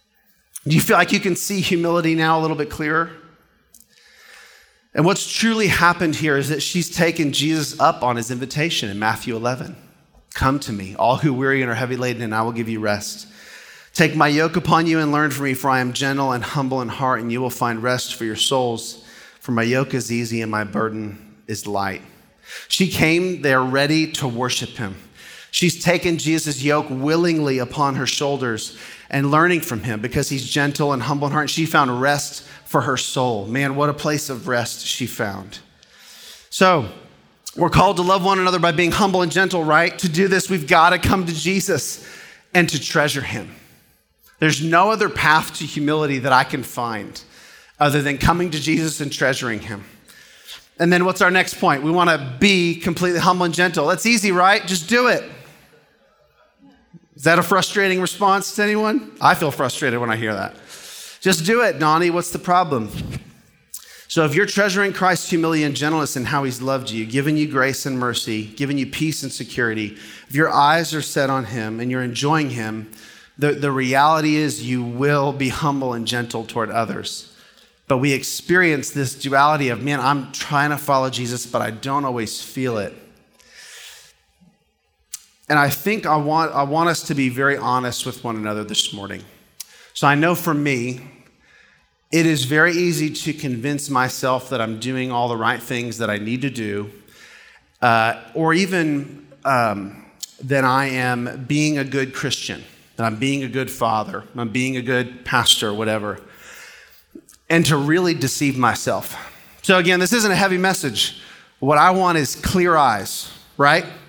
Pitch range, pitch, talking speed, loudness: 125-165 Hz, 145 Hz, 185 wpm, -19 LUFS